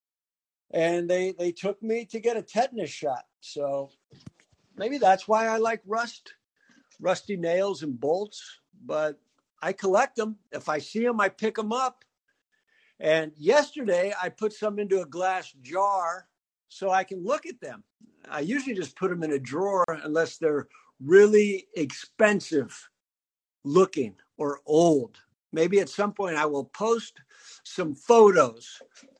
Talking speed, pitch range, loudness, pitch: 150 wpm, 160-220 Hz, -26 LUFS, 190 Hz